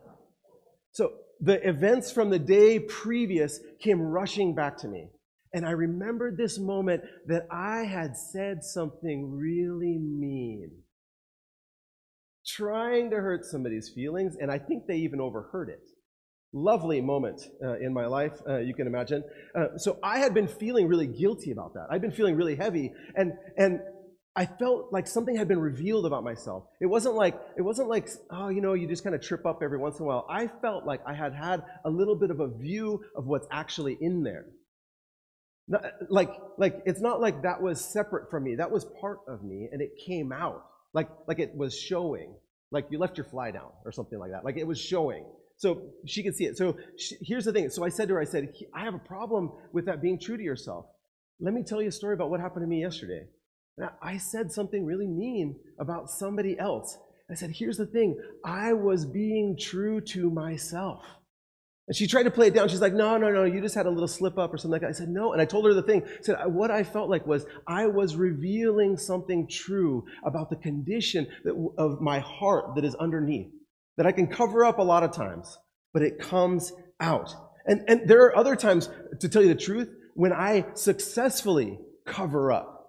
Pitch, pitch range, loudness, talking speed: 180 Hz, 155-205 Hz, -28 LUFS, 210 wpm